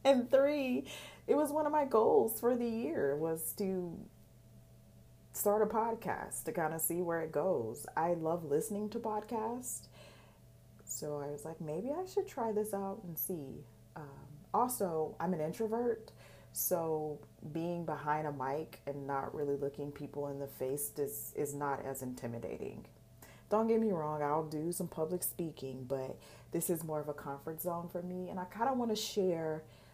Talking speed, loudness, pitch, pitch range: 180 wpm, -36 LUFS, 165 Hz, 145-210 Hz